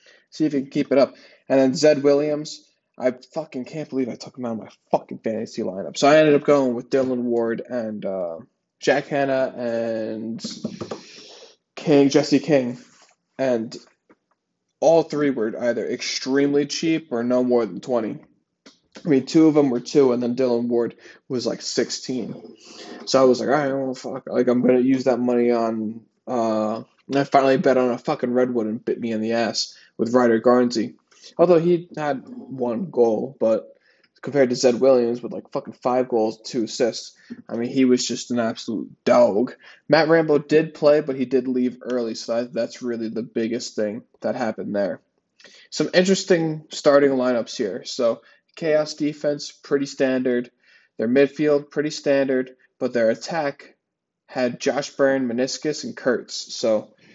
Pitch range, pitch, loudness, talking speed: 120-145 Hz, 130 Hz, -21 LUFS, 175 wpm